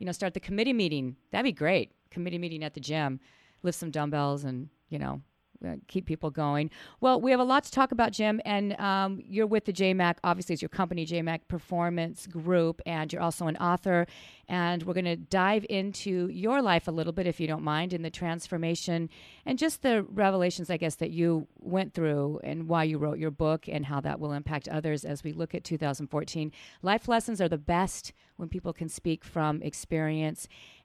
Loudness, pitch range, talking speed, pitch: -30 LUFS, 155-190 Hz, 205 wpm, 170 Hz